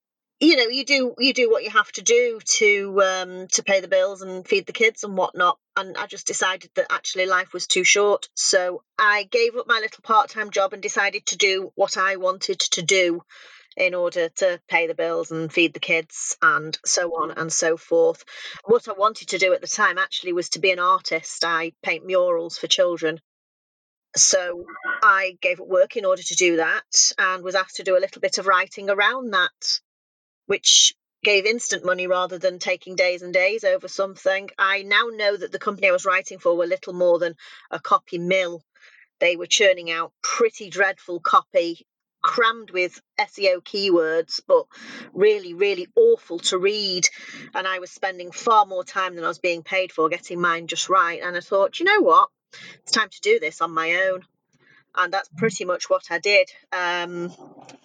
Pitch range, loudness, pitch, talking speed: 175-225 Hz, -21 LUFS, 190 Hz, 200 wpm